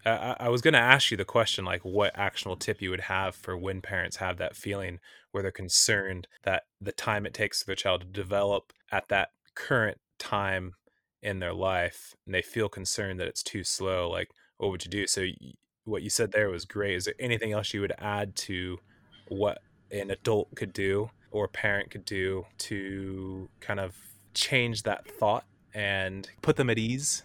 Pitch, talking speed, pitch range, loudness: 100 Hz, 205 wpm, 95-105 Hz, -29 LUFS